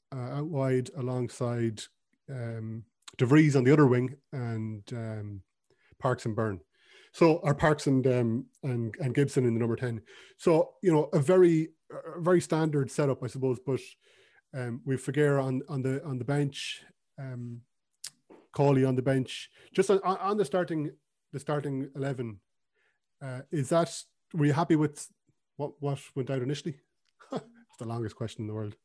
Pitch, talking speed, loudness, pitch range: 135 Hz, 165 wpm, -29 LUFS, 125-150 Hz